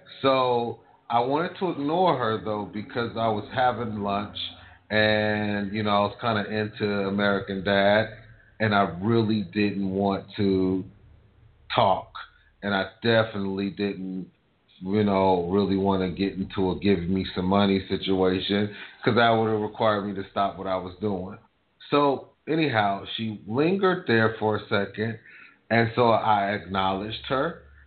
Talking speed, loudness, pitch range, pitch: 155 wpm, -25 LUFS, 95-110 Hz, 105 Hz